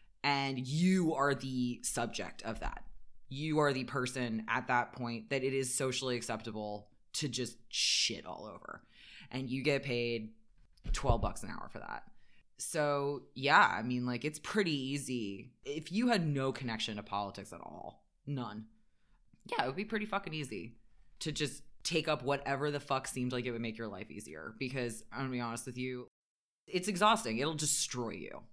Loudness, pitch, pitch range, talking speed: -35 LUFS, 130 Hz, 115-145 Hz, 180 wpm